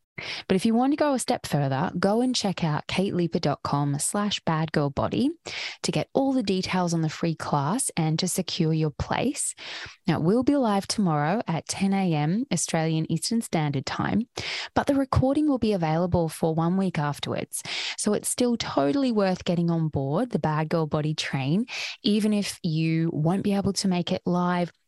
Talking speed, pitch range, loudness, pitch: 180 wpm, 160-210 Hz, -25 LUFS, 180 Hz